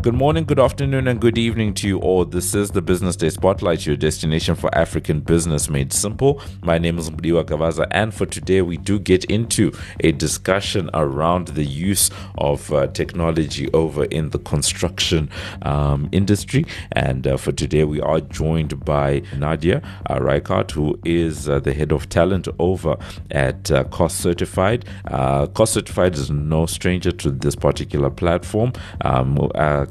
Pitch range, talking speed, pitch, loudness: 75-95 Hz, 170 wpm, 85 Hz, -19 LUFS